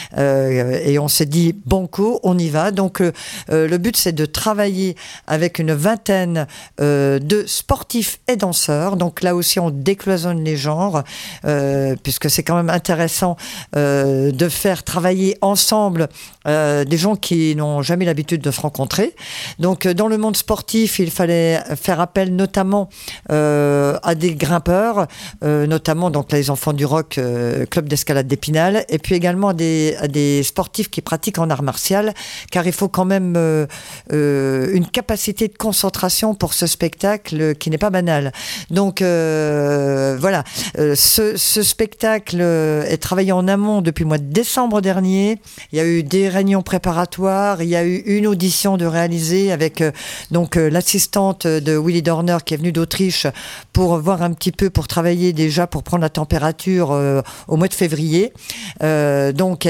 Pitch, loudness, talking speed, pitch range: 175 Hz, -17 LUFS, 175 wpm, 155-195 Hz